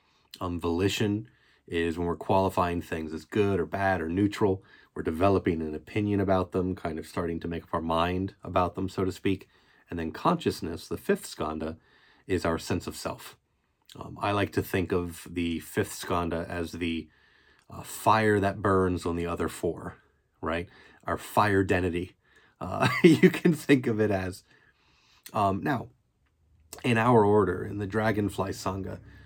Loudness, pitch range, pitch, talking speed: -28 LUFS, 85-100 Hz, 95 Hz, 170 wpm